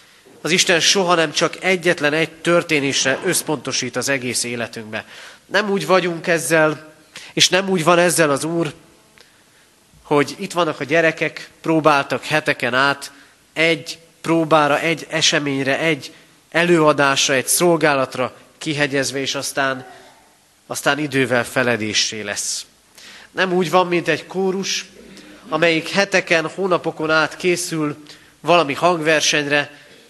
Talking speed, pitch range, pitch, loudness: 120 wpm, 140-170 Hz, 155 Hz, -18 LUFS